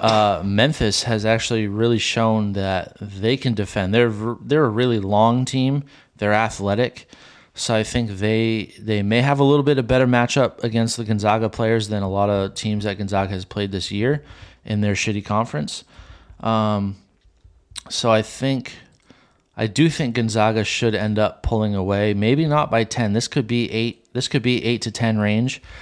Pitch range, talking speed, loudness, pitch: 105-120 Hz, 180 wpm, -20 LUFS, 110 Hz